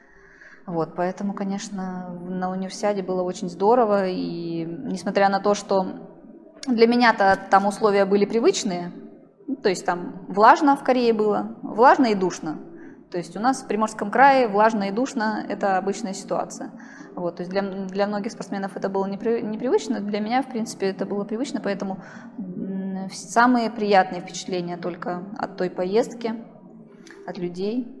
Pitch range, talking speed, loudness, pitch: 190-230 Hz, 150 wpm, -23 LUFS, 205 Hz